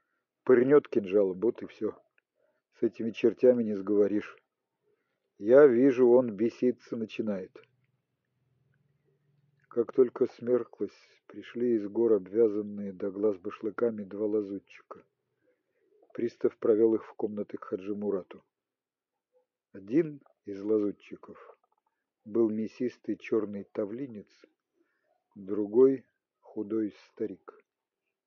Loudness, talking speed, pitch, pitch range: -29 LUFS, 95 wpm, 120 Hz, 105-145 Hz